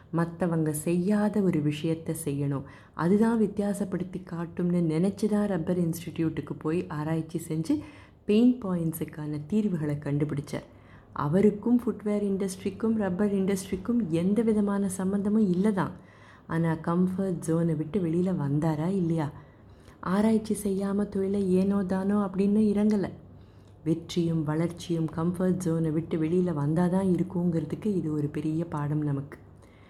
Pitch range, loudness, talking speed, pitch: 155-200 Hz, -28 LUFS, 110 wpm, 175 Hz